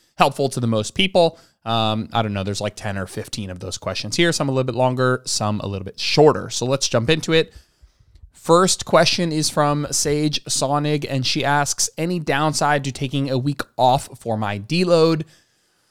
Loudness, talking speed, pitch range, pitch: -20 LUFS, 195 wpm, 110-155 Hz, 135 Hz